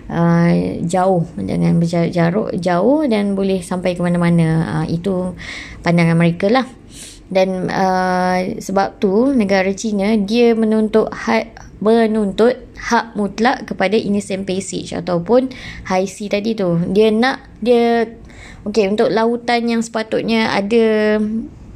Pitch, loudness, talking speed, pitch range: 200 Hz, -16 LUFS, 120 wpm, 180-225 Hz